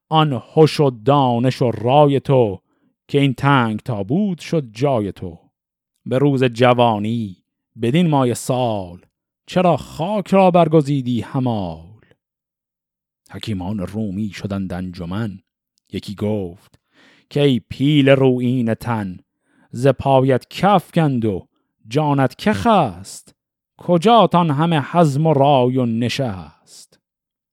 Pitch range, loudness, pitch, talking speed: 105-150 Hz, -17 LUFS, 125 Hz, 115 wpm